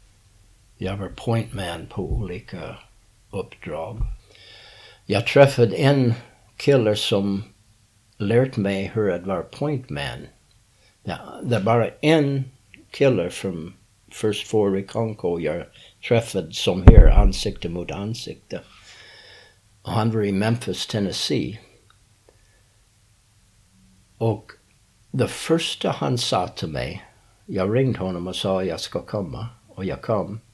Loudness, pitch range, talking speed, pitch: -22 LUFS, 100-115 Hz, 95 wpm, 105 Hz